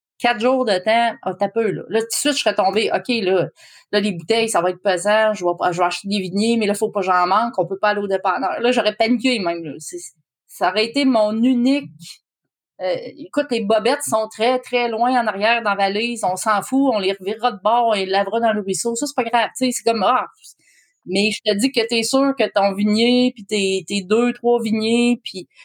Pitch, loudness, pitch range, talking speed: 220 Hz, -19 LUFS, 195-240 Hz, 255 wpm